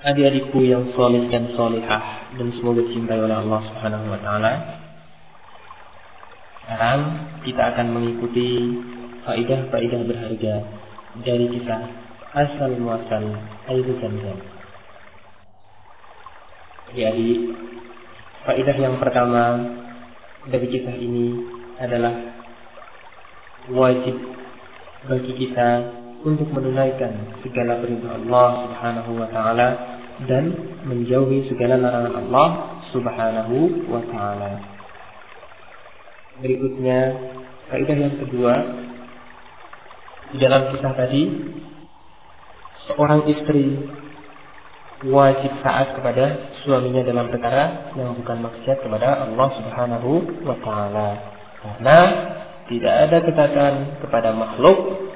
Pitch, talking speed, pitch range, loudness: 125 Hz, 90 wpm, 115-135 Hz, -20 LUFS